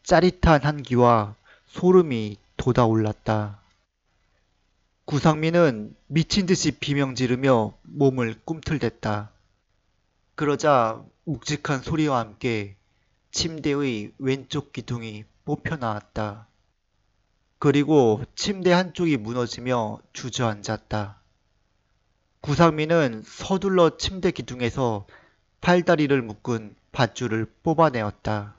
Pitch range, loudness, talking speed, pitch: 105-150 Hz, -23 LUFS, 210 characters per minute, 120 Hz